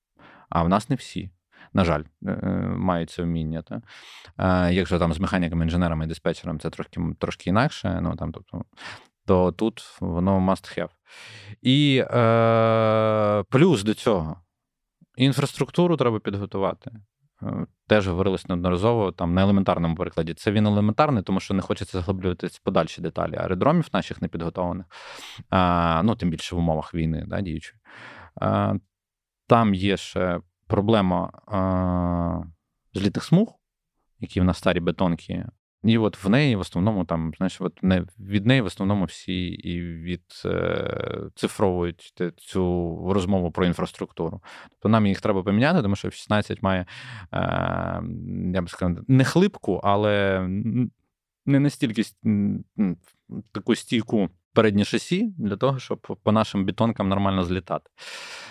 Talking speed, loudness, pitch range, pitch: 140 wpm, -24 LUFS, 90-110 Hz, 95 Hz